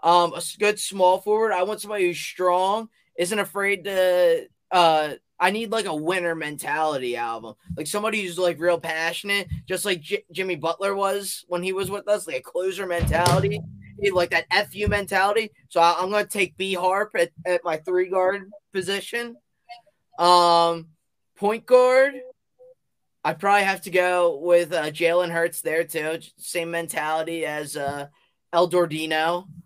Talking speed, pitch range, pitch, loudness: 160 wpm, 170-200 Hz, 180 Hz, -23 LUFS